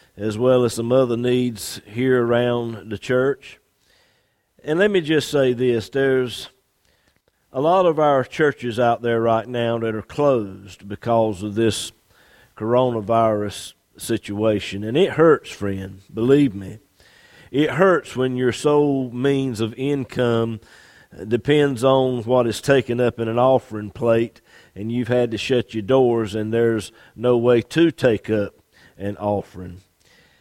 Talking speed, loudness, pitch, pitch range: 145 wpm, -20 LUFS, 120 Hz, 110-130 Hz